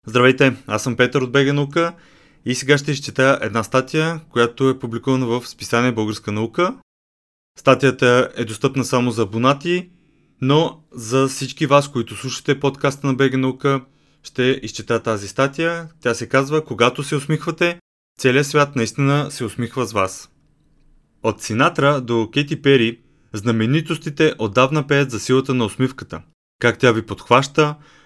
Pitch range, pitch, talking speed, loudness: 120-145 Hz, 130 Hz, 150 wpm, -19 LUFS